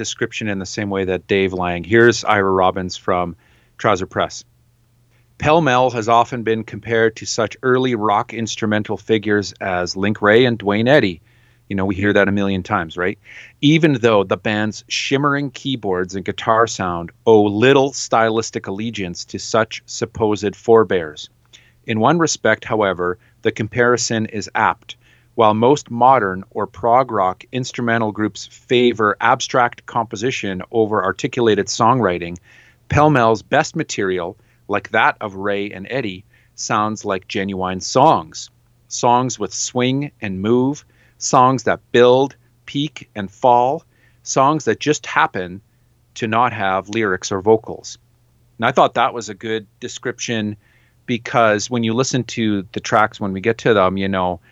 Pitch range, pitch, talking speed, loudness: 100-120 Hz, 115 Hz, 150 wpm, -18 LUFS